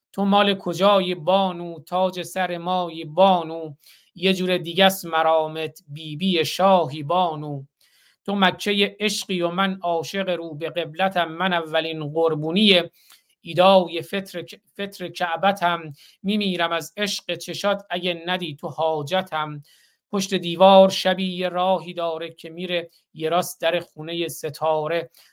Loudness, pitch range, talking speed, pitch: -22 LUFS, 165-190 Hz, 125 wpm, 175 Hz